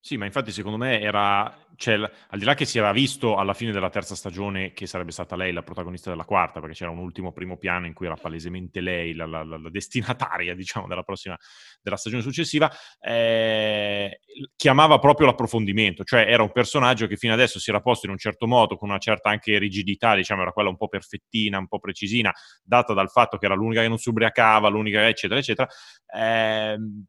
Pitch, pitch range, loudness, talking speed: 105 Hz, 95-115 Hz, -22 LUFS, 215 wpm